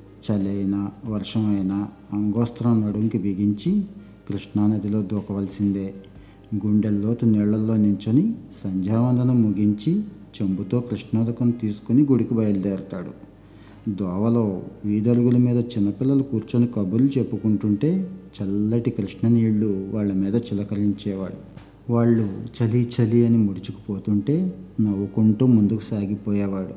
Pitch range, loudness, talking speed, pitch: 100-115 Hz, -22 LUFS, 85 wpm, 105 Hz